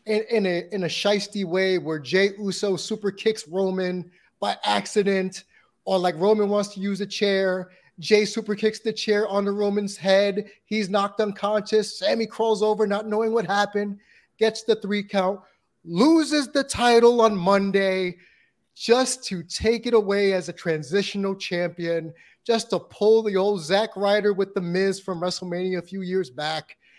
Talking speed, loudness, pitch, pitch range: 170 wpm, -23 LUFS, 200 Hz, 185-215 Hz